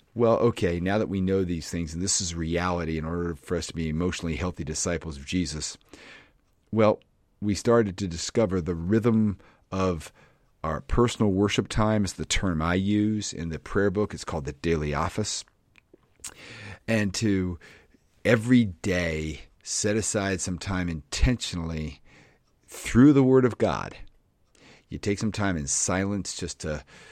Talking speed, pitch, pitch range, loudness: 155 wpm, 95 Hz, 85-105 Hz, -26 LUFS